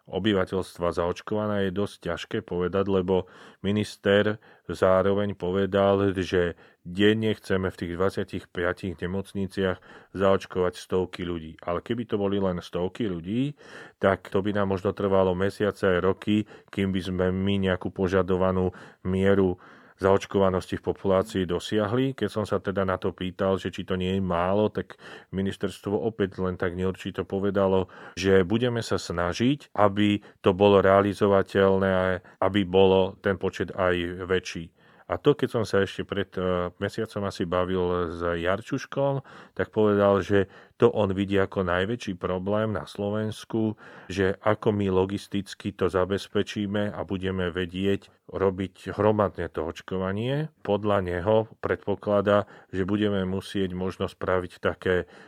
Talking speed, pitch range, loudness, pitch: 135 wpm, 95-100 Hz, -26 LUFS, 95 Hz